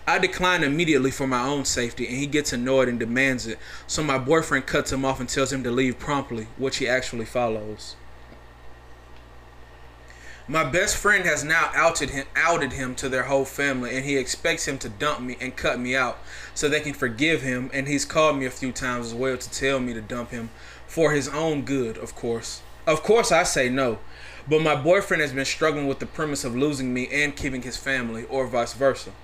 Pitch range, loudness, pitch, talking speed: 120-145 Hz, -24 LUFS, 135 Hz, 215 wpm